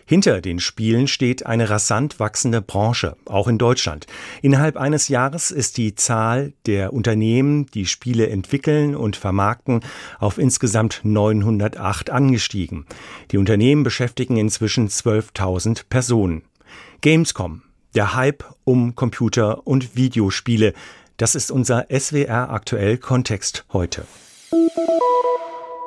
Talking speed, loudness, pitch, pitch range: 110 wpm, -19 LUFS, 115 Hz, 105-130 Hz